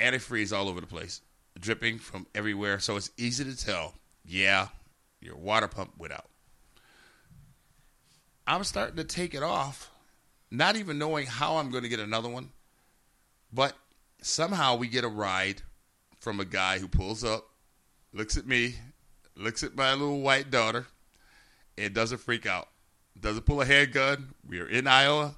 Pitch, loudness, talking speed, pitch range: 115 Hz, -29 LUFS, 160 wpm, 100-135 Hz